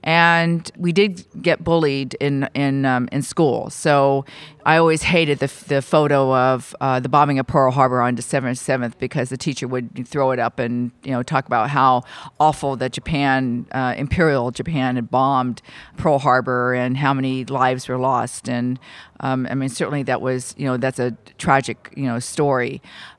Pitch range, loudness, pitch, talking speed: 125-145 Hz, -19 LUFS, 130 Hz, 185 wpm